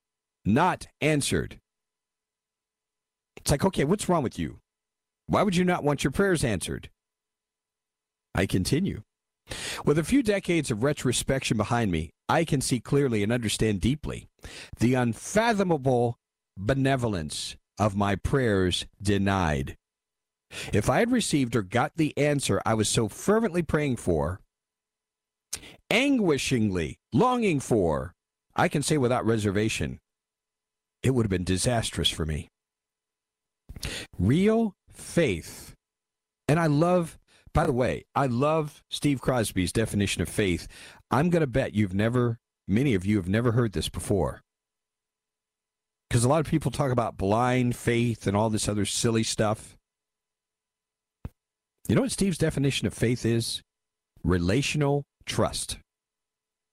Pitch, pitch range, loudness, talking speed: 115 Hz, 95-145 Hz, -26 LUFS, 130 wpm